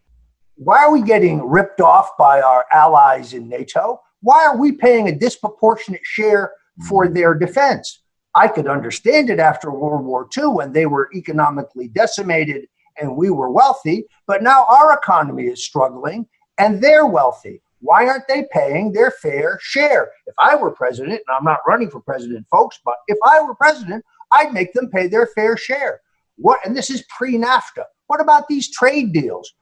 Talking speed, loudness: 175 wpm, -15 LUFS